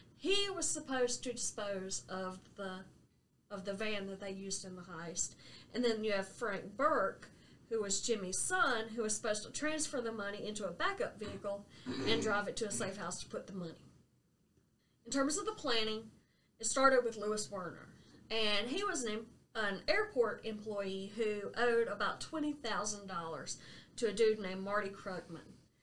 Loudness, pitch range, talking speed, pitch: -37 LUFS, 195-240 Hz, 175 wpm, 215 Hz